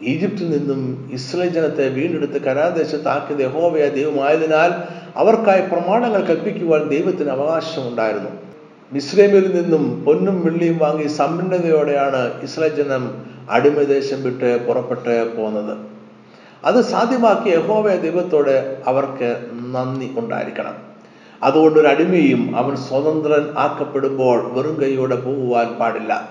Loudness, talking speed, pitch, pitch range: -18 LUFS, 95 wpm, 145 Hz, 130-170 Hz